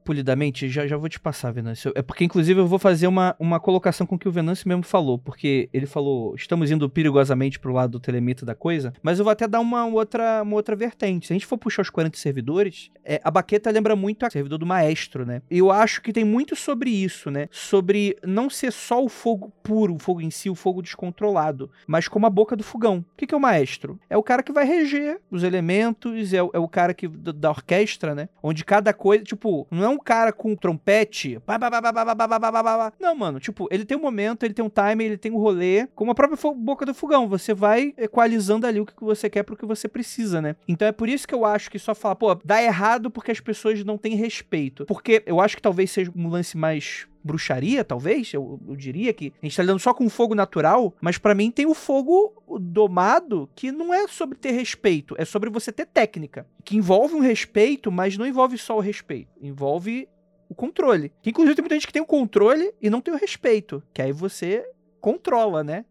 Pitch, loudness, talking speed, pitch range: 210 Hz, -22 LUFS, 230 wpm, 170-230 Hz